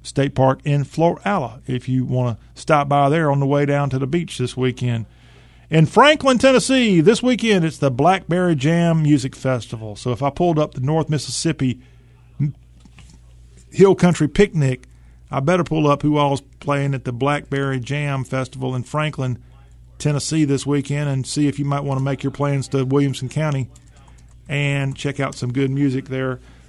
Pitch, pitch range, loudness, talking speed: 140 Hz, 130-150 Hz, -19 LUFS, 180 wpm